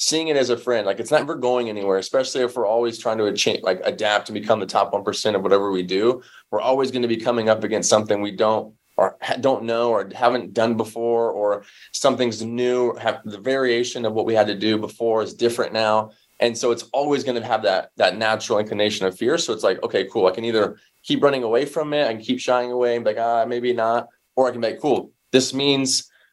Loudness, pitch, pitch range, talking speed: -21 LUFS, 115 Hz, 110-125 Hz, 245 wpm